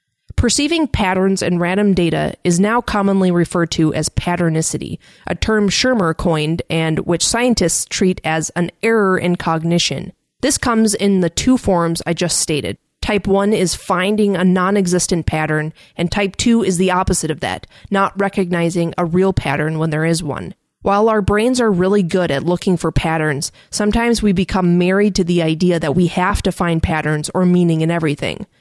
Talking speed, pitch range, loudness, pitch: 180 wpm, 165-200 Hz, -16 LUFS, 180 Hz